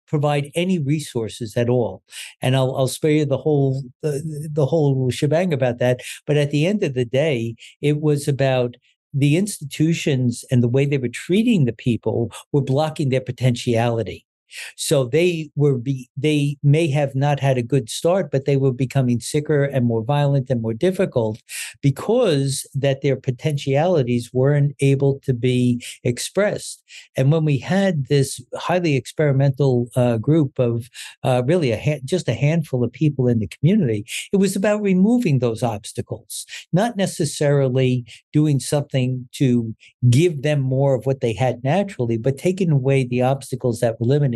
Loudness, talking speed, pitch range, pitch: -20 LUFS, 165 wpm, 125-150 Hz, 135 Hz